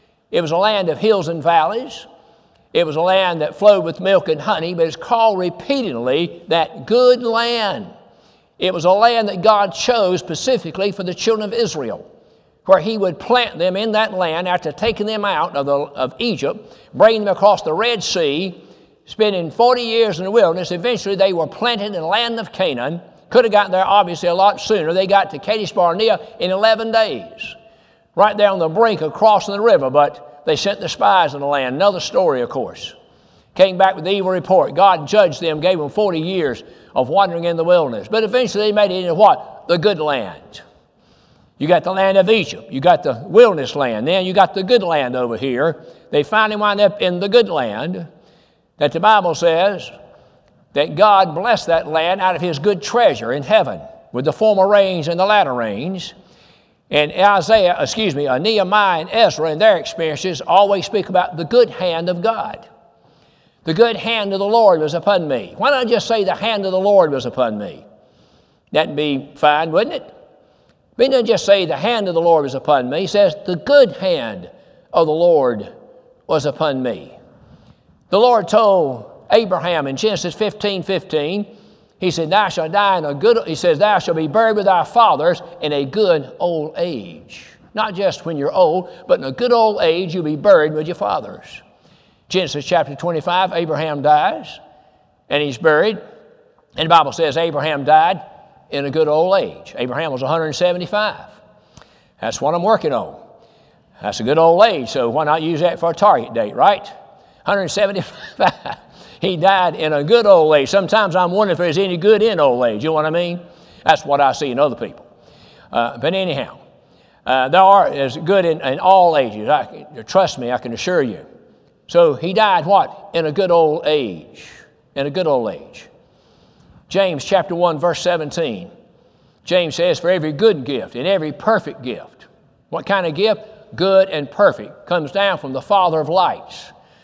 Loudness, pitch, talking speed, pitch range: -16 LUFS, 190 Hz, 195 wpm, 165-215 Hz